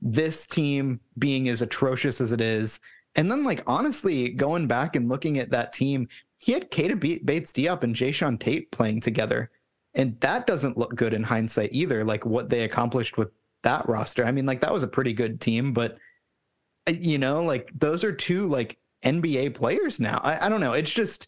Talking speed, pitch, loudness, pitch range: 200 wpm, 130 Hz, -25 LUFS, 115-145 Hz